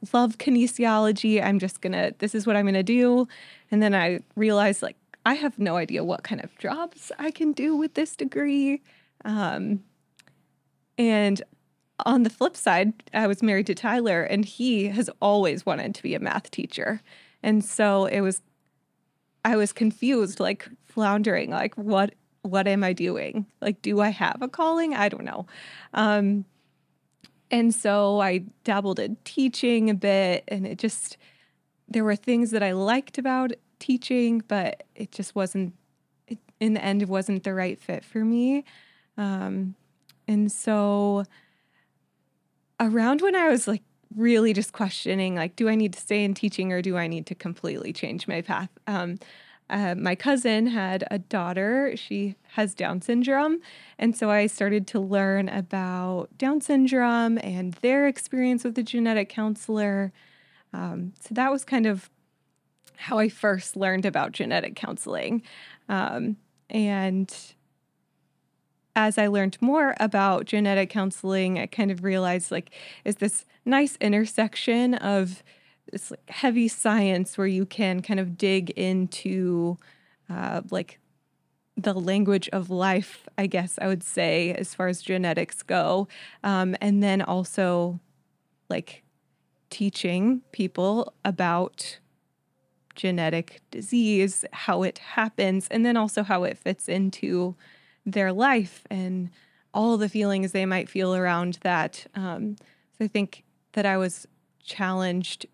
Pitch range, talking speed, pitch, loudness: 190-230 Hz, 150 wpm, 205 Hz, -25 LUFS